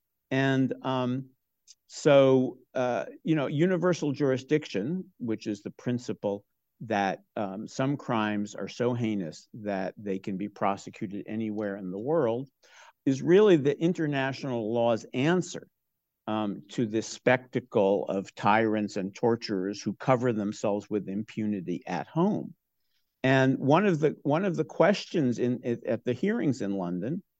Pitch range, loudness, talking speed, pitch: 105-135 Hz, -28 LUFS, 140 wpm, 120 Hz